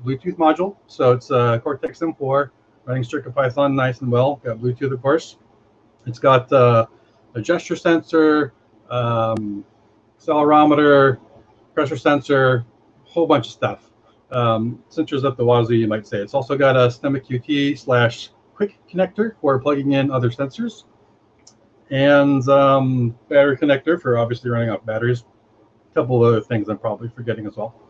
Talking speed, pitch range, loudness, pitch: 160 wpm, 115-140 Hz, -19 LUFS, 125 Hz